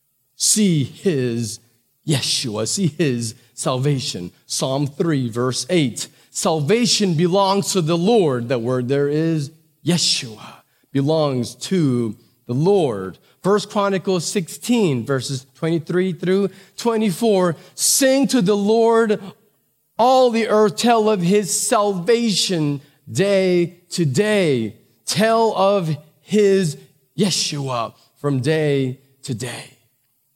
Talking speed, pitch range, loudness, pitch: 105 wpm, 135-200 Hz, -19 LUFS, 165 Hz